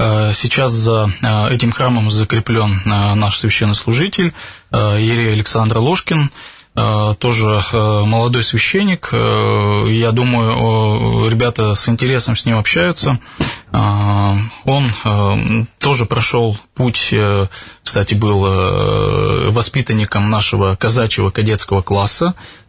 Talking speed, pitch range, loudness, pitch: 85 wpm, 105-120 Hz, -14 LUFS, 110 Hz